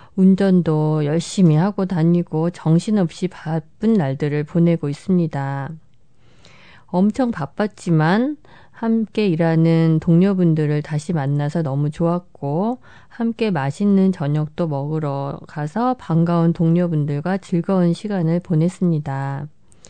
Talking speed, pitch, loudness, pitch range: 255 characters per minute, 170 Hz, -19 LUFS, 150-190 Hz